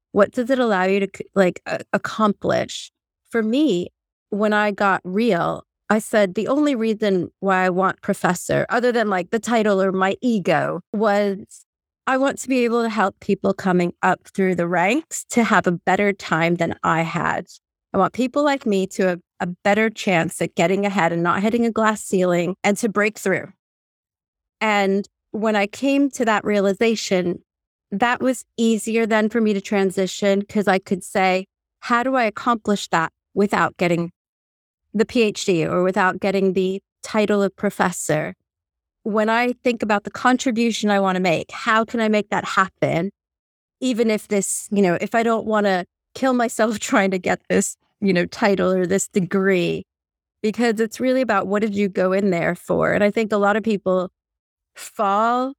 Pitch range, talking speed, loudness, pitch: 185-225 Hz, 180 wpm, -20 LUFS, 205 Hz